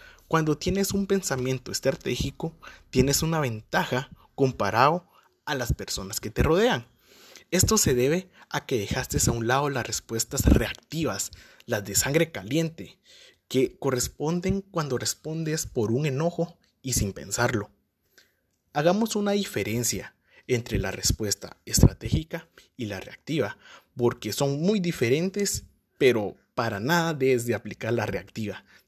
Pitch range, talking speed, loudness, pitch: 115-165 Hz, 130 wpm, -26 LUFS, 130 Hz